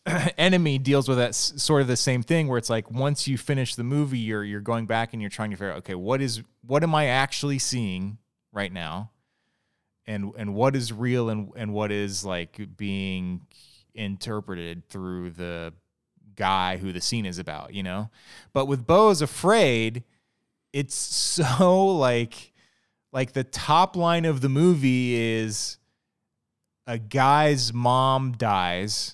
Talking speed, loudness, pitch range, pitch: 160 wpm, -24 LUFS, 100-135 Hz, 115 Hz